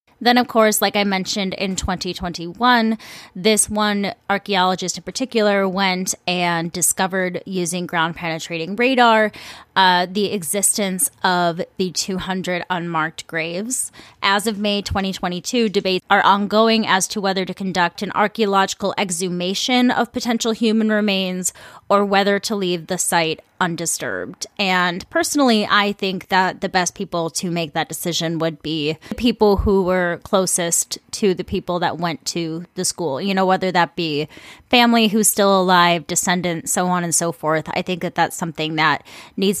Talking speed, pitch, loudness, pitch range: 155 wpm, 190 Hz, -19 LUFS, 175-205 Hz